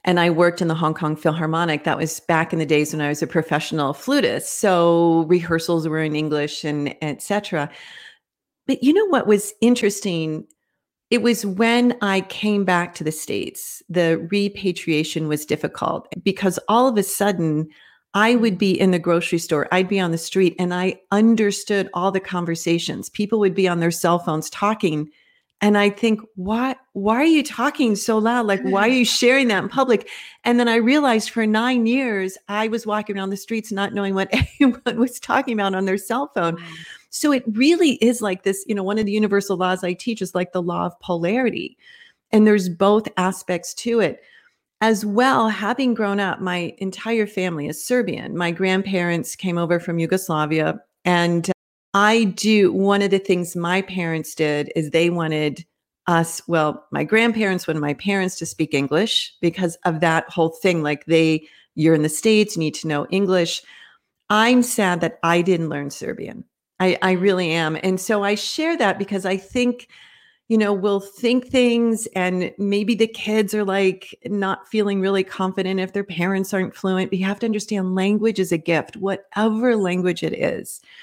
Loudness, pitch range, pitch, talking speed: -20 LUFS, 170-220 Hz, 195 Hz, 190 wpm